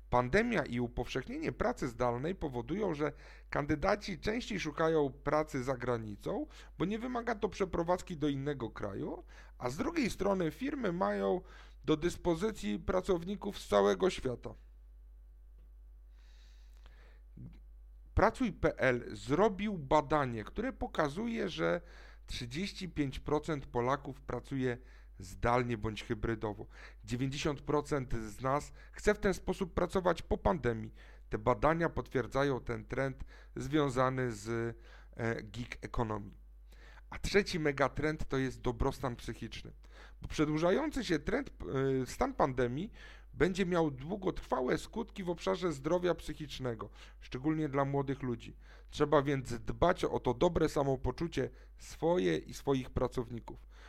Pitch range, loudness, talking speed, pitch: 120-175 Hz, -35 LUFS, 110 wpm, 140 Hz